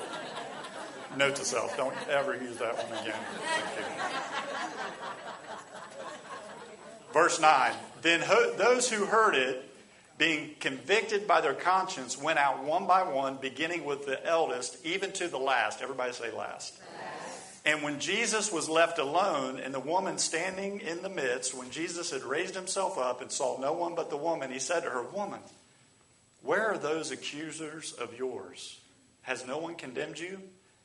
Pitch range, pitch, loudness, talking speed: 135-190 Hz, 165 Hz, -30 LUFS, 160 wpm